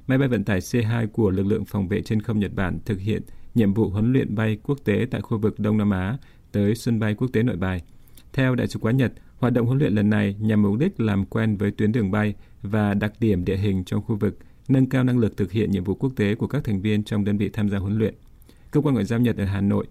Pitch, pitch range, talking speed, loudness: 105 Hz, 100-115 Hz, 280 wpm, -23 LUFS